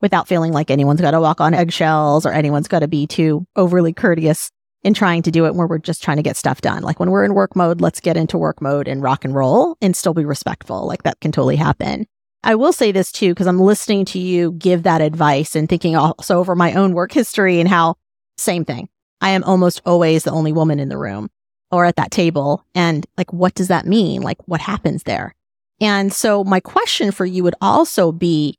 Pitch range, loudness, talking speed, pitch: 155-190 Hz, -16 LUFS, 235 wpm, 175 Hz